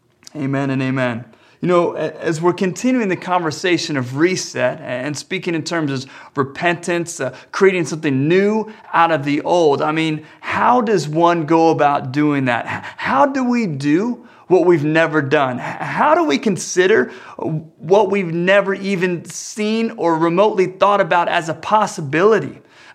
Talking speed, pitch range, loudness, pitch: 155 wpm, 150-195 Hz, -17 LUFS, 170 Hz